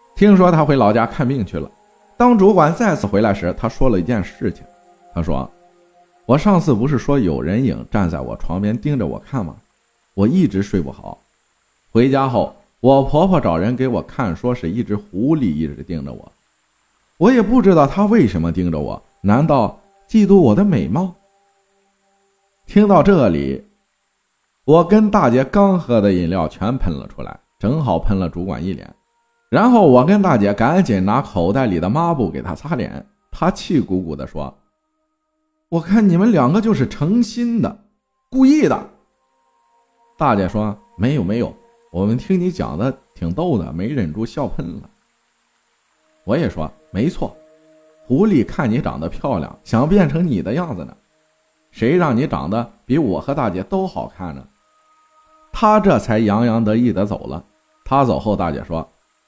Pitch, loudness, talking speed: 155 Hz, -17 LUFS, 235 characters per minute